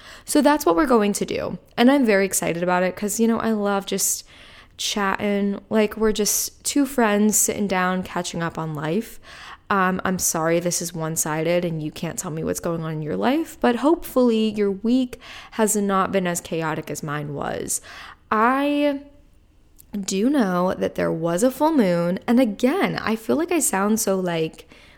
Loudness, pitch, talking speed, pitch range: -21 LUFS, 200 Hz, 190 wpm, 175-230 Hz